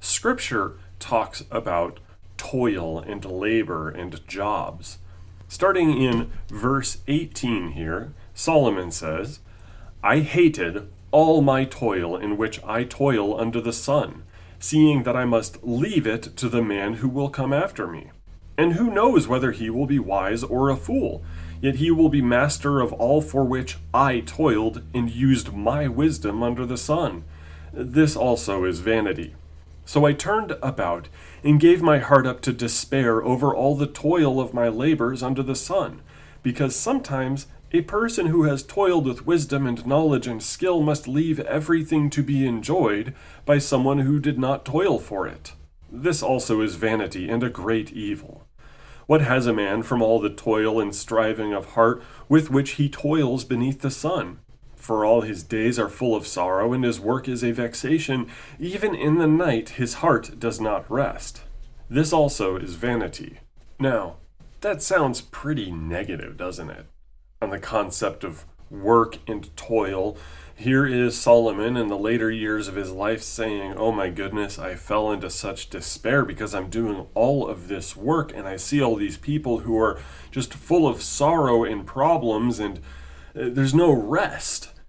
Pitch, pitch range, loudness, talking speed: 115 Hz, 100-140 Hz, -23 LUFS, 165 wpm